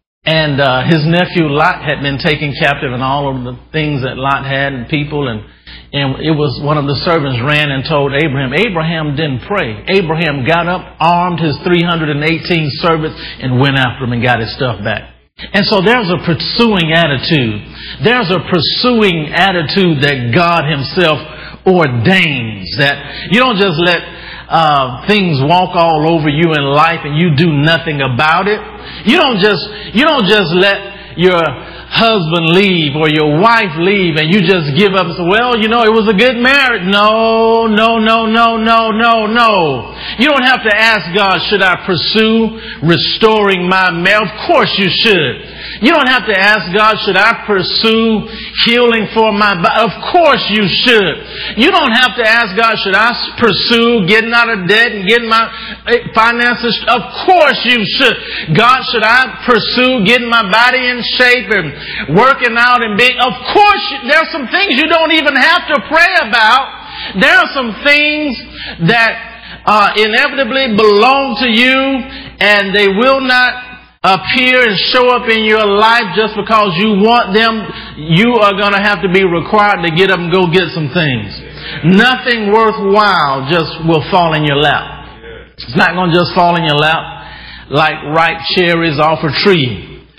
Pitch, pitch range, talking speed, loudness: 195 Hz, 160-225 Hz, 175 wpm, -10 LUFS